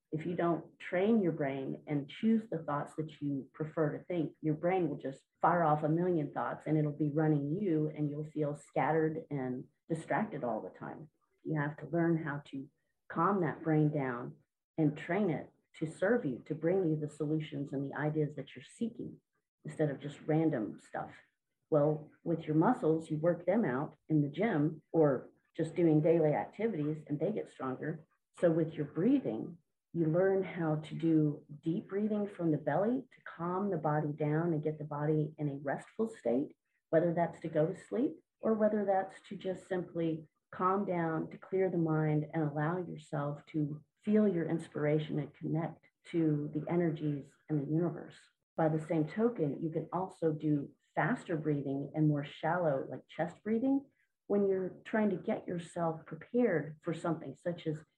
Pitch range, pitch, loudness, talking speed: 150-175 Hz, 160 Hz, -34 LUFS, 185 wpm